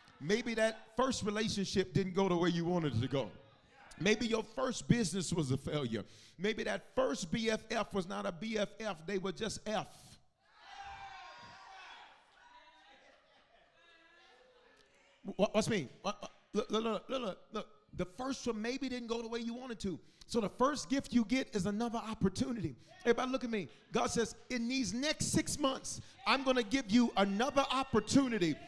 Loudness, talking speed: -35 LUFS, 160 wpm